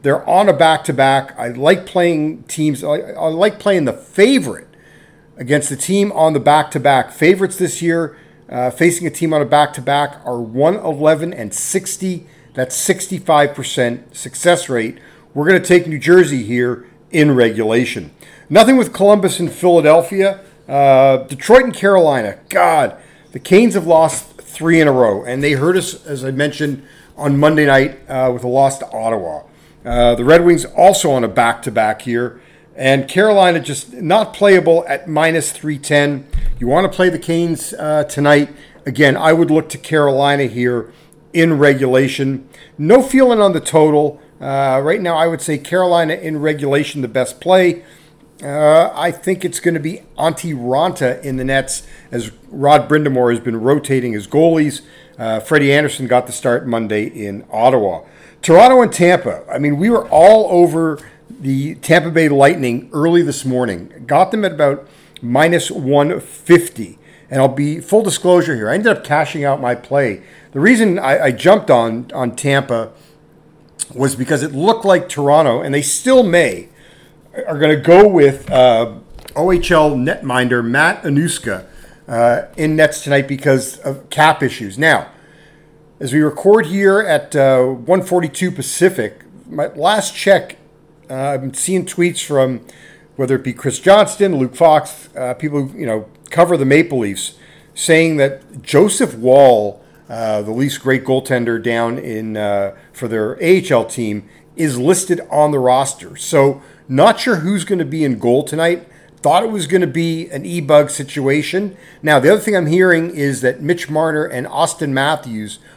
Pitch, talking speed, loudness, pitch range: 150 Hz, 170 wpm, -14 LUFS, 130-170 Hz